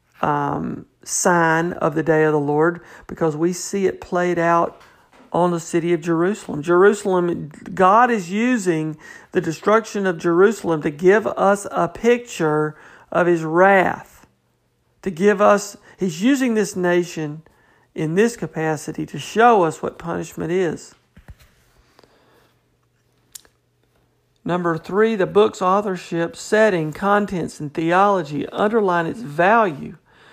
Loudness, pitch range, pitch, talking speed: -19 LUFS, 165-205 Hz, 175 Hz, 125 wpm